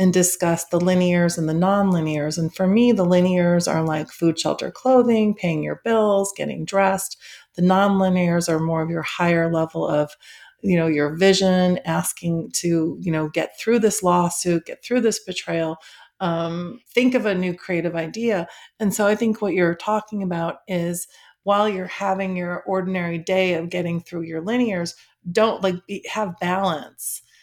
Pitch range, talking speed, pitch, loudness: 170-195 Hz, 175 wpm, 180 Hz, -21 LUFS